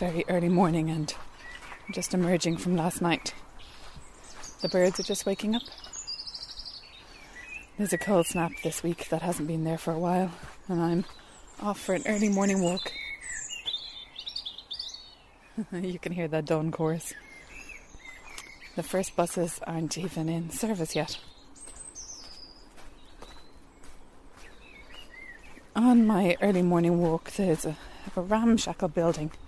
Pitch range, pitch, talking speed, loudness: 165-190 Hz, 175 Hz, 120 wpm, -29 LUFS